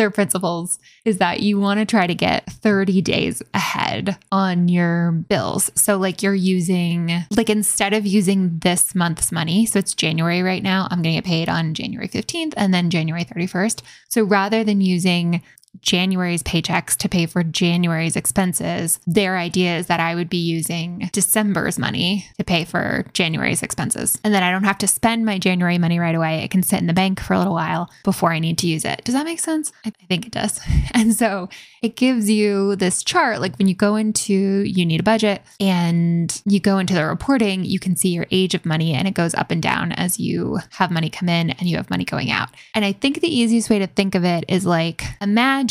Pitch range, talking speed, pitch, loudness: 170-205 Hz, 220 wpm, 185 Hz, -19 LUFS